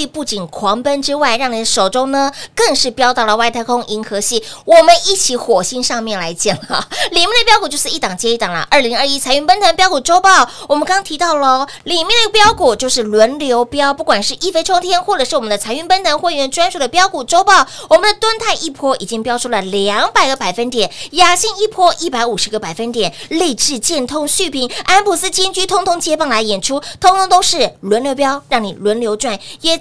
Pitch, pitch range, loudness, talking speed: 275 Hz, 230-350 Hz, -13 LUFS, 325 characters per minute